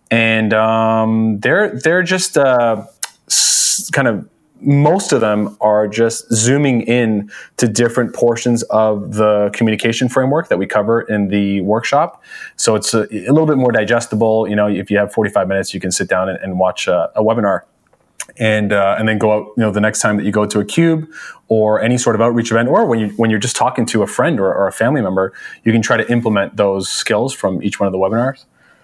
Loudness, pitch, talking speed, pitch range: -15 LUFS, 110 Hz, 220 wpm, 105-120 Hz